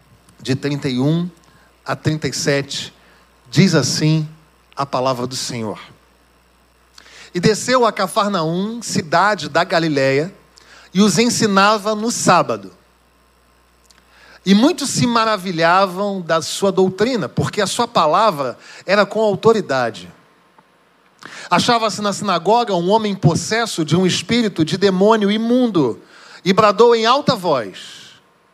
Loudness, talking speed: -16 LUFS, 110 wpm